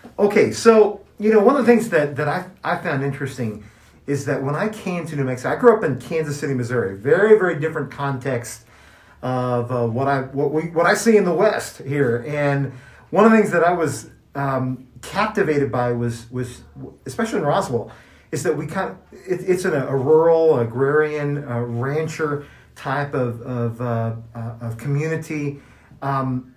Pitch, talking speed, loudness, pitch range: 140 Hz, 185 wpm, -20 LUFS, 125-165 Hz